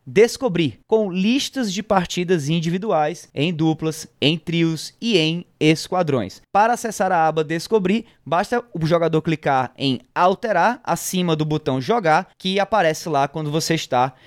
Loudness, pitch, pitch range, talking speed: -20 LUFS, 165 Hz, 155-195 Hz, 145 wpm